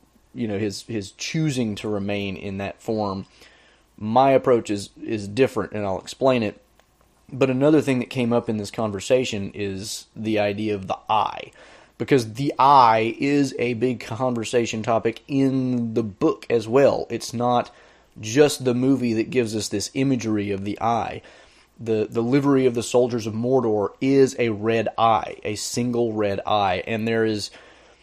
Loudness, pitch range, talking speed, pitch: -22 LUFS, 105-130 Hz, 170 wpm, 115 Hz